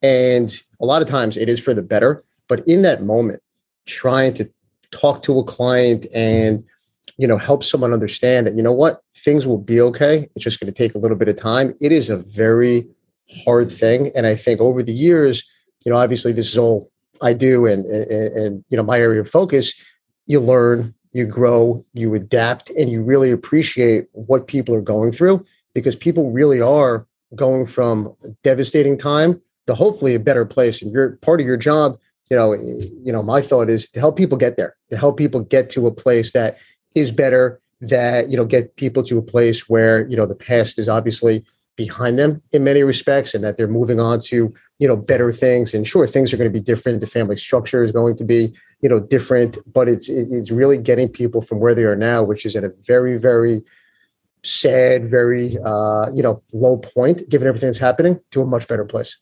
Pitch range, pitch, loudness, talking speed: 115-130 Hz, 120 Hz, -16 LUFS, 210 wpm